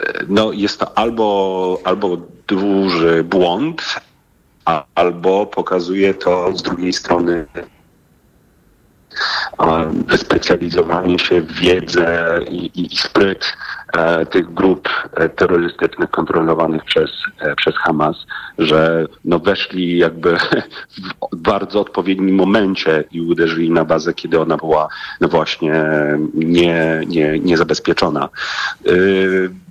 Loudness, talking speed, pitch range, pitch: -16 LUFS, 105 wpm, 80-95 Hz, 85 Hz